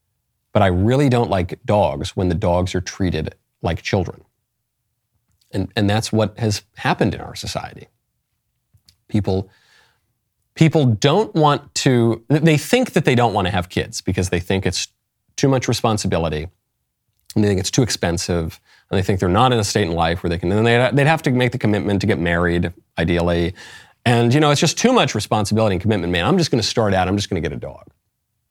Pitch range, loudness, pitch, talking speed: 90-120 Hz, -18 LUFS, 105 Hz, 205 wpm